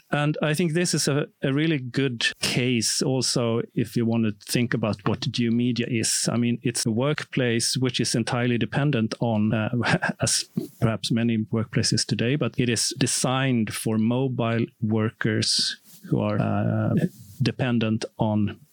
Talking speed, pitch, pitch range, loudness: 155 wpm, 120 Hz, 115-135 Hz, -24 LUFS